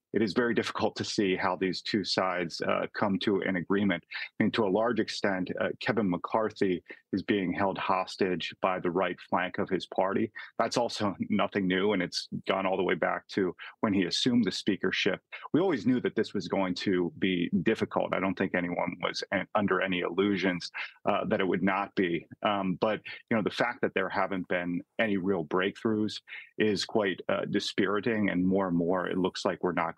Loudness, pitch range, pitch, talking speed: -30 LUFS, 90-100 Hz, 95 Hz, 205 wpm